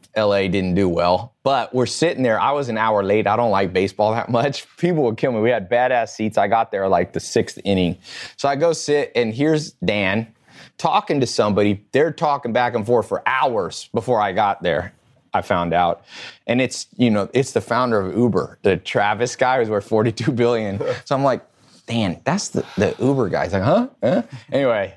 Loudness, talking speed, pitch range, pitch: -20 LUFS, 210 wpm, 100-125 Hz, 115 Hz